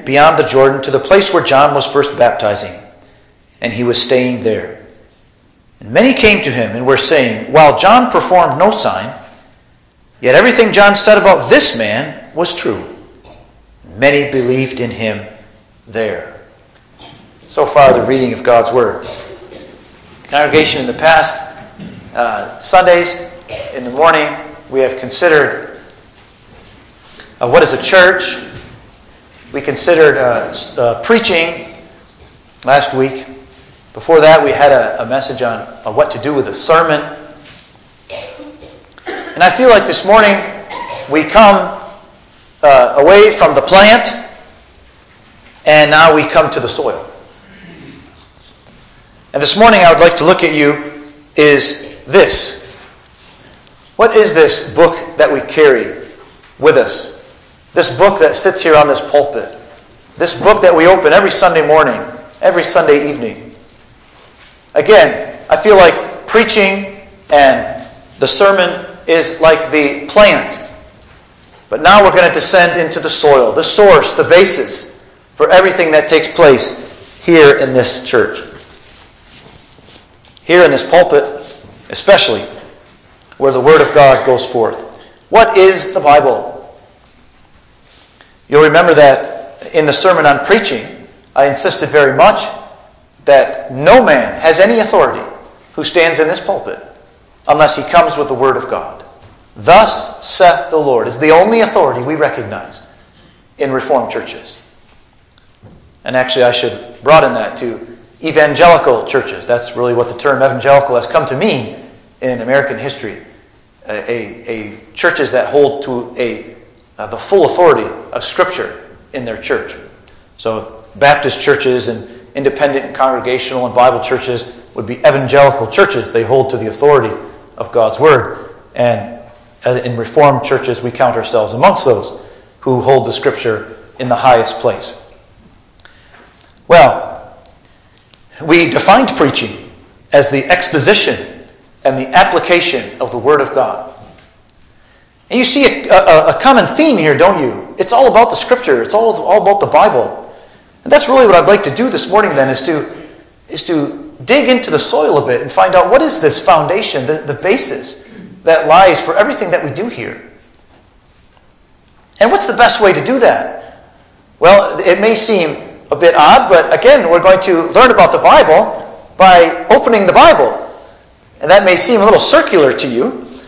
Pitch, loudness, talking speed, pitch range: 155 Hz, -9 LUFS, 150 wpm, 130-195 Hz